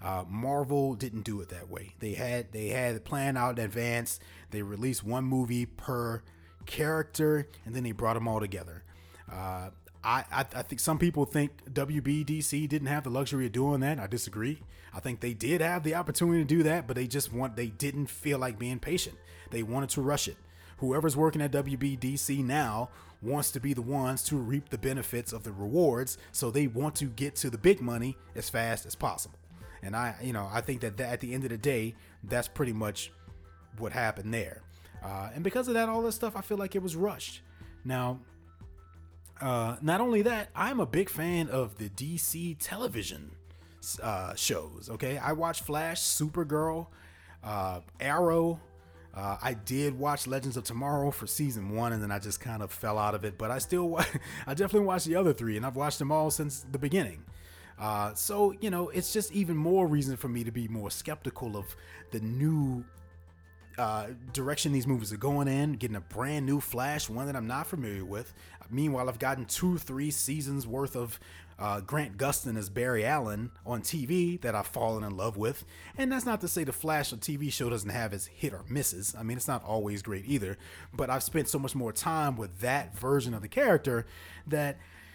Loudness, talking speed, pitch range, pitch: -32 LUFS, 205 wpm, 105-145 Hz, 125 Hz